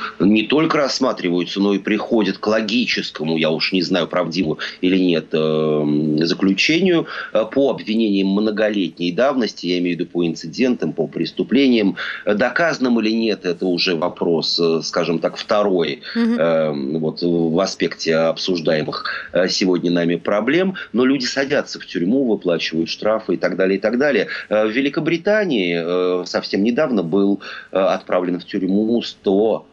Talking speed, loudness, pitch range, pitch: 140 wpm, -18 LUFS, 85-110 Hz, 95 Hz